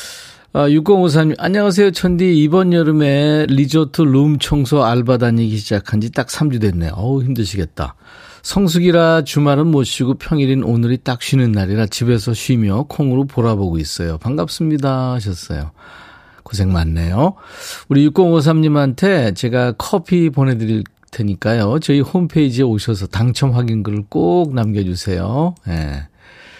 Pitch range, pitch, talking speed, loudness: 105-155 Hz, 130 Hz, 300 characters per minute, -15 LUFS